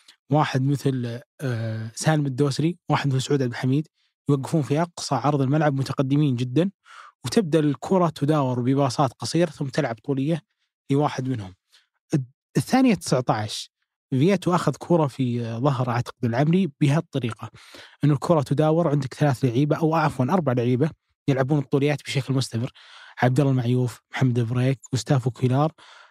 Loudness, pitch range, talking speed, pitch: -23 LUFS, 130-155 Hz, 135 wpm, 140 Hz